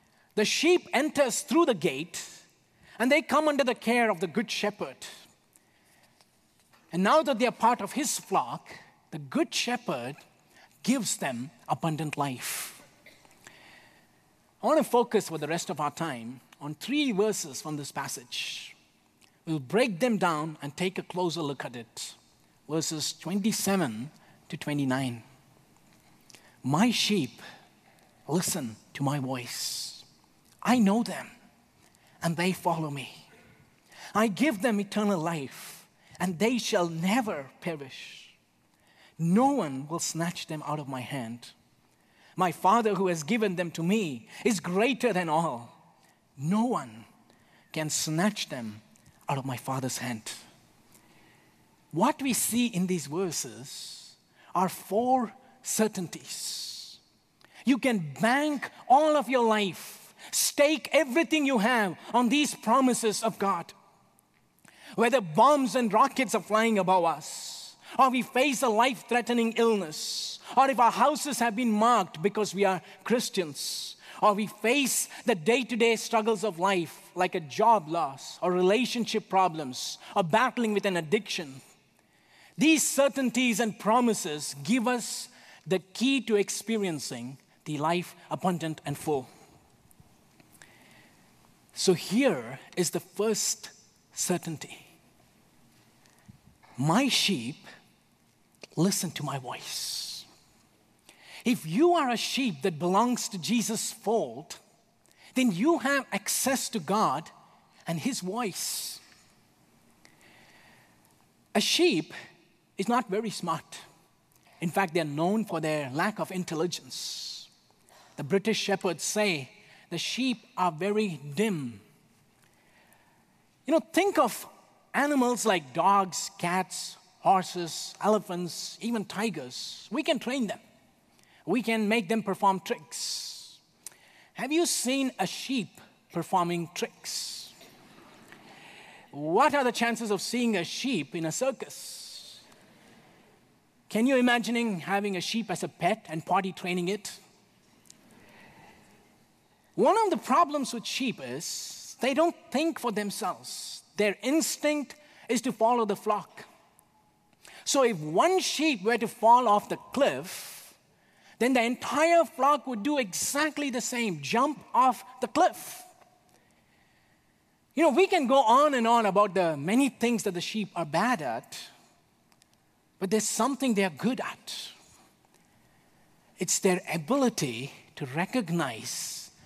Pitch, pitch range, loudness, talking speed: 205 Hz, 170-245 Hz, -28 LUFS, 130 wpm